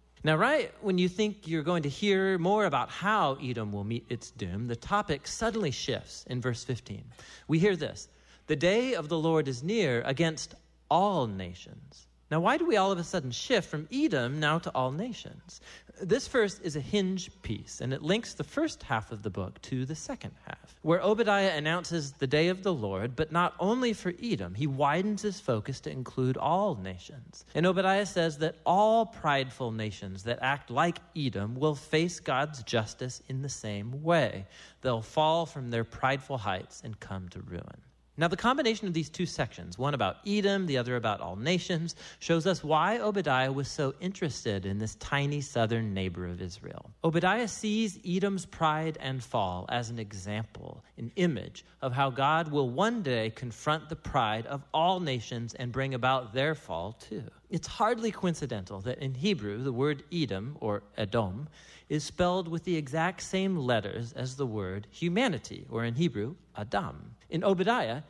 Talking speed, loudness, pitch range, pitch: 180 wpm, -30 LUFS, 115-180 Hz, 145 Hz